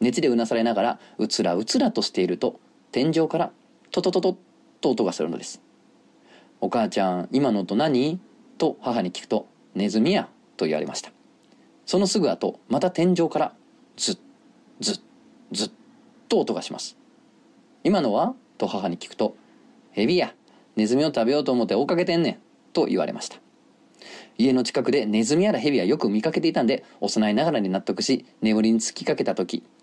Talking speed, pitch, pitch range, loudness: 340 characters per minute, 115 Hz, 110-165 Hz, -24 LUFS